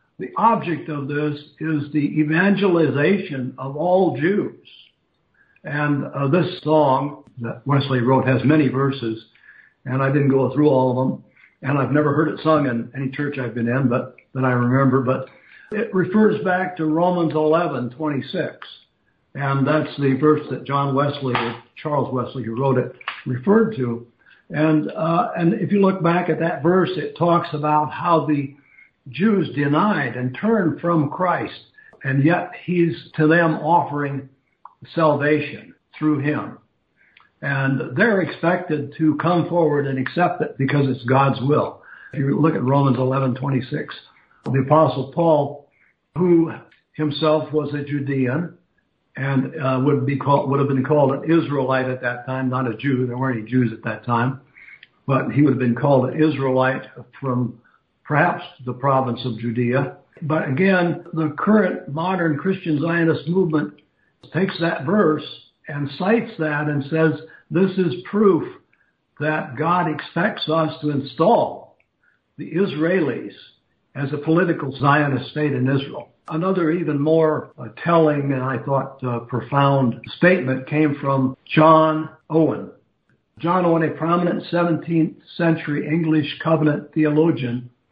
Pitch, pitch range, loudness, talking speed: 150 Hz, 135-165 Hz, -20 LUFS, 150 wpm